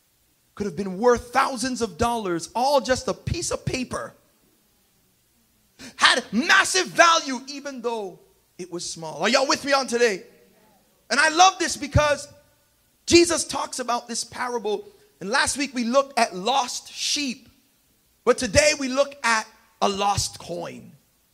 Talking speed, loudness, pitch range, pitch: 150 wpm, -22 LUFS, 230-285 Hz, 255 Hz